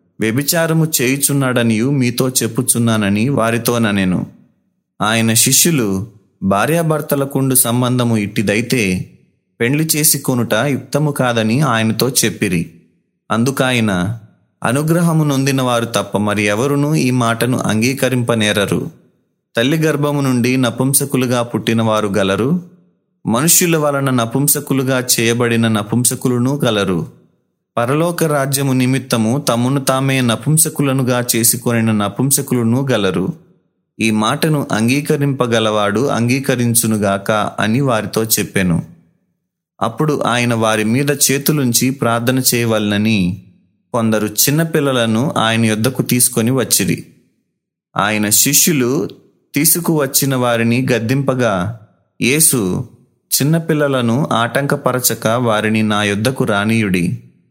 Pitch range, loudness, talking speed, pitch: 110-140 Hz, -15 LUFS, 85 wpm, 120 Hz